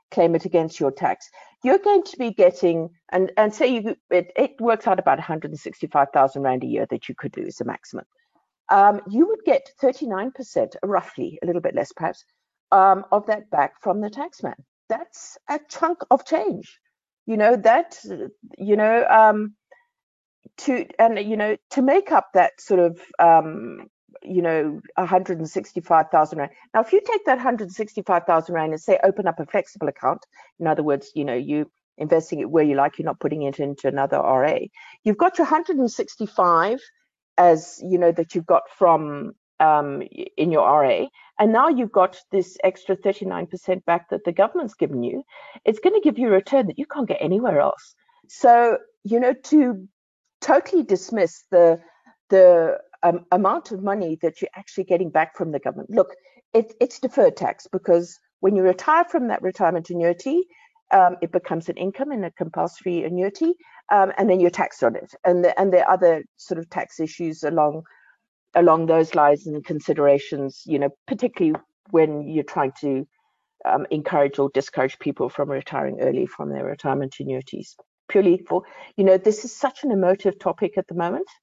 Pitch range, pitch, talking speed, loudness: 165-245 Hz, 185 Hz, 185 wpm, -21 LUFS